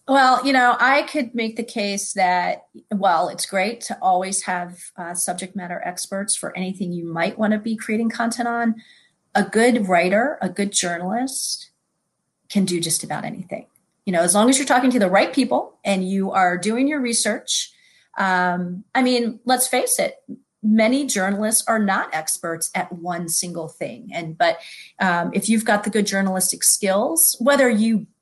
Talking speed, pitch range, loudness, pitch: 180 wpm, 185-240 Hz, -20 LUFS, 210 Hz